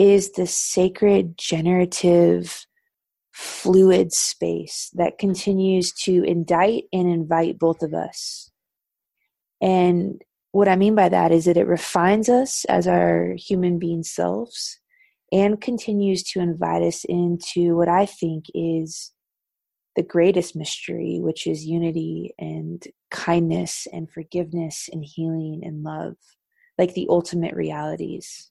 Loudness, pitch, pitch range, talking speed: -21 LUFS, 175 Hz, 165-190 Hz, 125 wpm